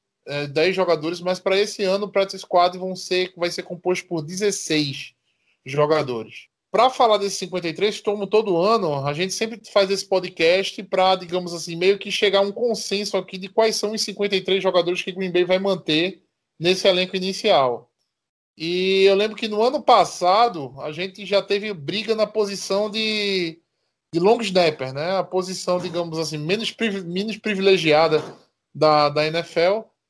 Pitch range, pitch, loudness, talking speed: 170-205 Hz, 190 Hz, -21 LUFS, 165 wpm